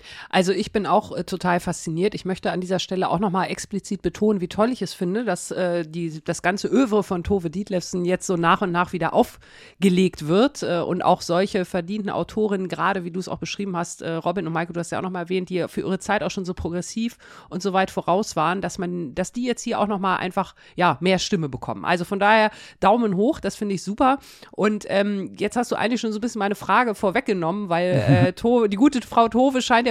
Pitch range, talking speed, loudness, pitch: 175-210 Hz, 235 wpm, -23 LUFS, 190 Hz